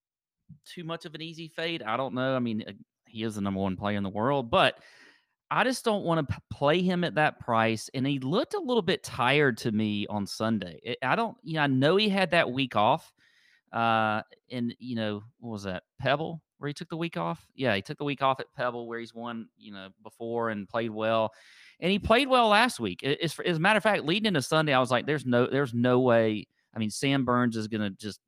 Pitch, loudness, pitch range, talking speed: 125 Hz, -28 LUFS, 110-165 Hz, 245 wpm